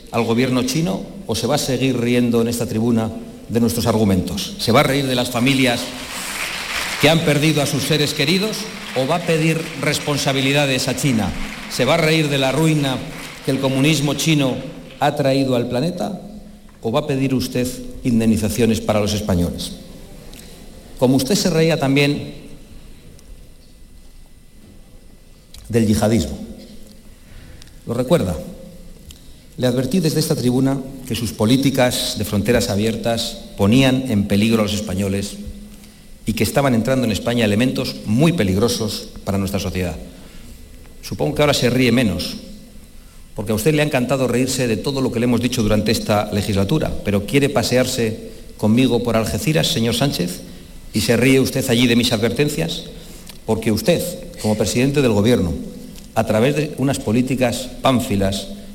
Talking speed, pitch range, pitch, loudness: 150 wpm, 110-140 Hz, 125 Hz, -18 LUFS